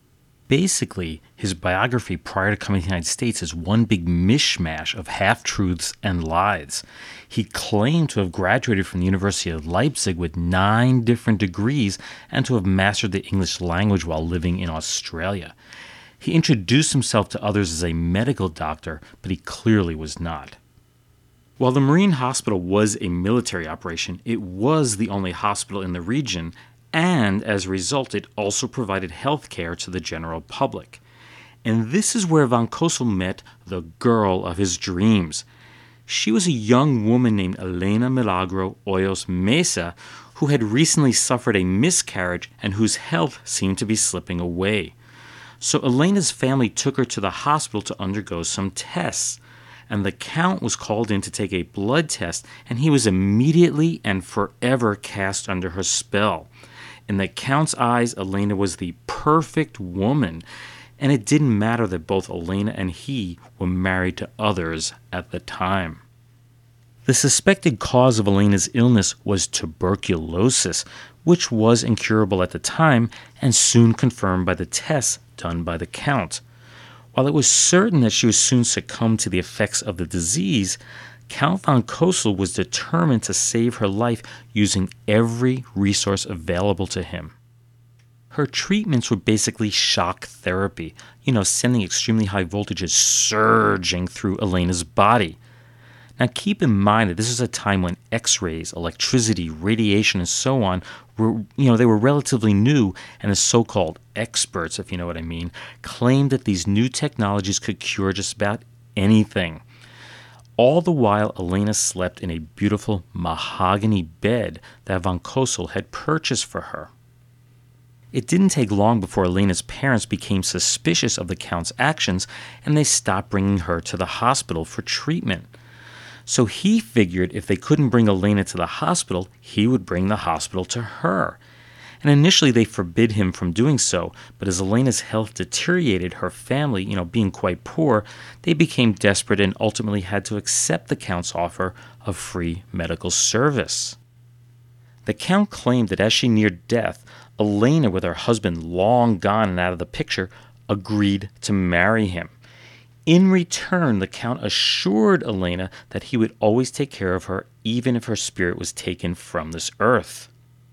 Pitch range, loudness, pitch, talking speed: 95-120 Hz, -21 LUFS, 110 Hz, 160 wpm